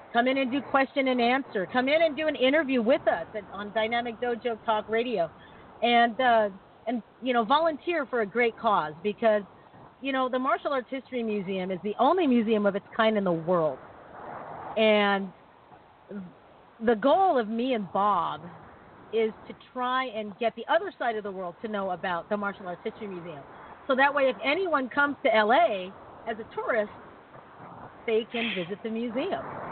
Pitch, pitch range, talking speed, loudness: 230 Hz, 205-260 Hz, 180 wpm, -27 LUFS